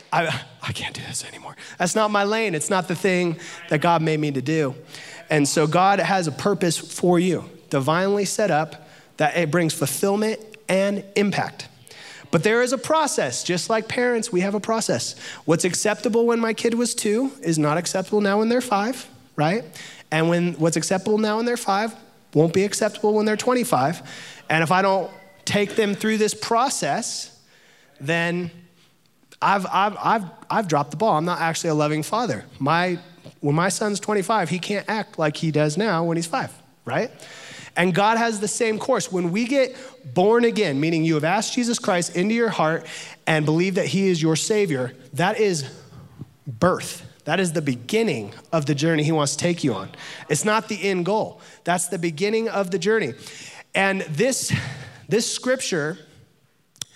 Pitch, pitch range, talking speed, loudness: 180 Hz, 155-215 Hz, 185 wpm, -22 LUFS